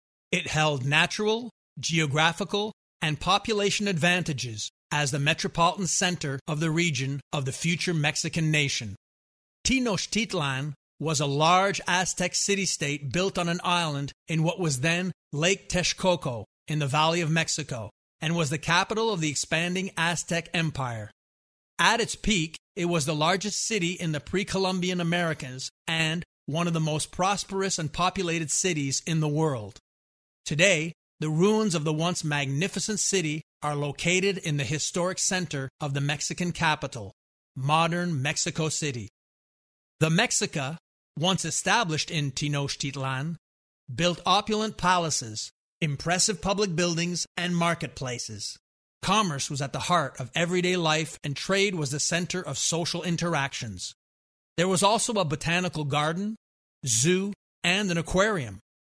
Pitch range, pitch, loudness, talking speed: 145-180 Hz, 165 Hz, -26 LUFS, 135 wpm